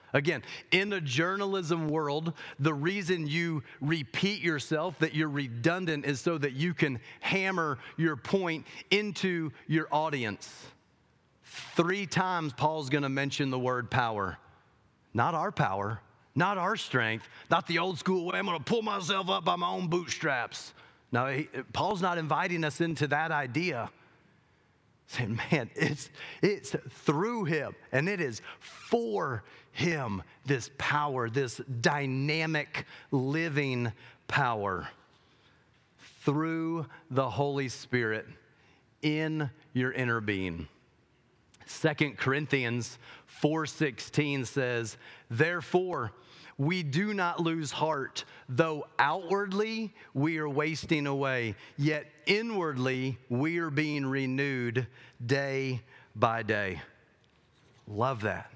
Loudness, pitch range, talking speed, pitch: -31 LUFS, 130-165 Hz, 120 wpm, 150 Hz